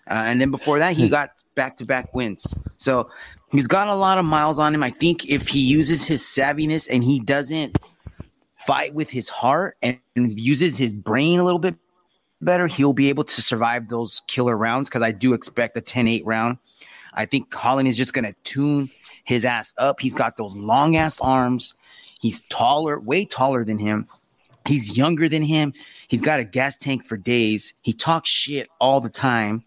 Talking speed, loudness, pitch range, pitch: 200 wpm, -20 LUFS, 120-150 Hz, 135 Hz